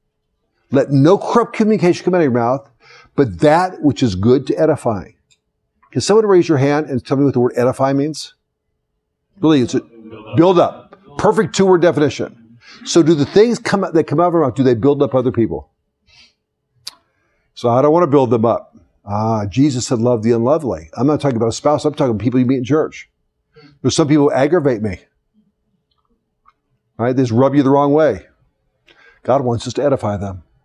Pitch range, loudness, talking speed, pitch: 120-155 Hz, -15 LUFS, 205 wpm, 140 Hz